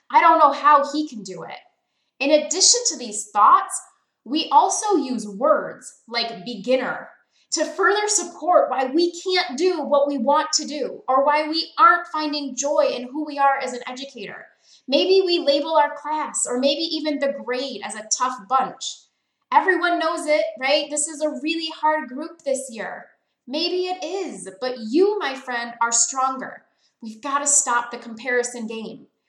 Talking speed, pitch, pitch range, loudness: 175 wpm, 290 Hz, 255-320 Hz, -20 LUFS